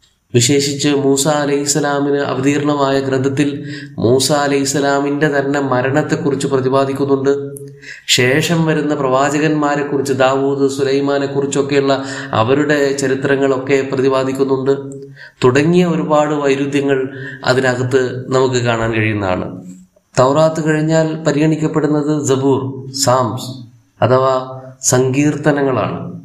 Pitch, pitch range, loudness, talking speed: 140 Hz, 130-145 Hz, -15 LUFS, 80 wpm